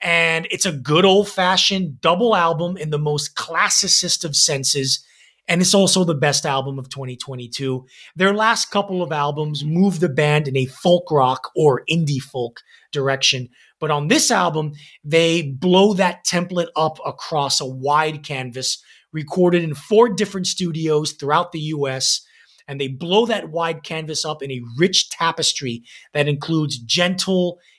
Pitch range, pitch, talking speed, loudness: 140-180 Hz, 155 Hz, 160 wpm, -18 LUFS